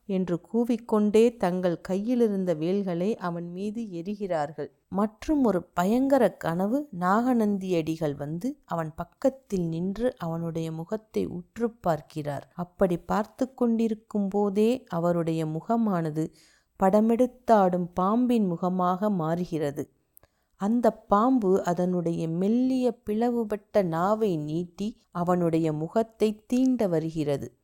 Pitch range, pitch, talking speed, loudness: 170-225 Hz, 190 Hz, 90 wpm, -27 LUFS